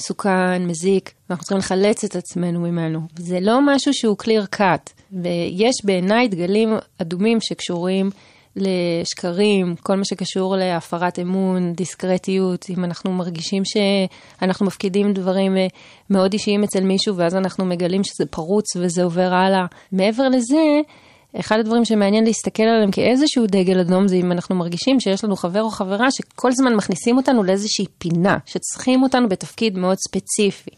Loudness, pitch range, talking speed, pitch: -19 LUFS, 180-215 Hz, 145 wpm, 195 Hz